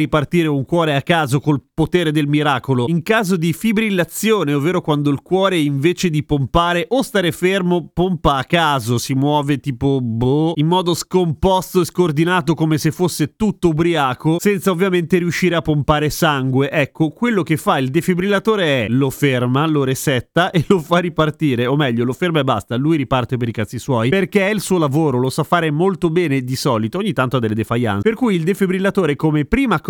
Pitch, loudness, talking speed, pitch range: 160 Hz, -17 LUFS, 195 wpm, 140-180 Hz